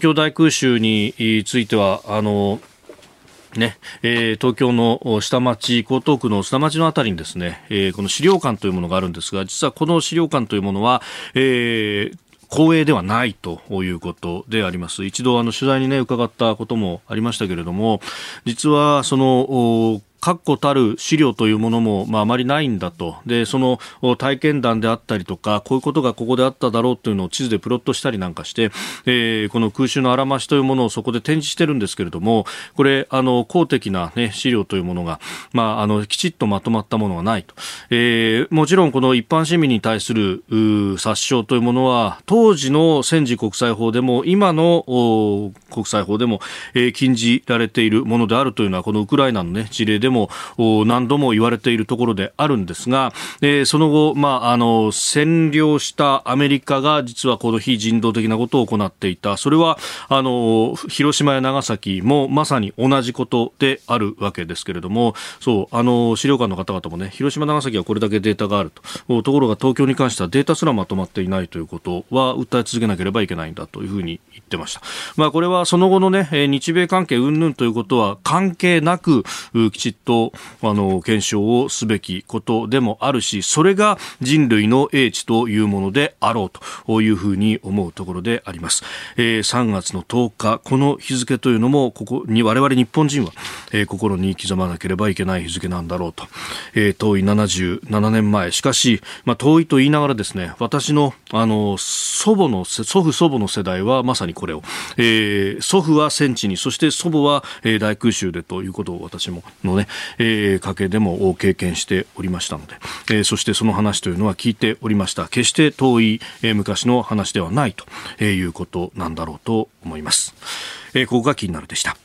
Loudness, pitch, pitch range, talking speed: -18 LUFS, 115 Hz, 105-135 Hz, 380 characters per minute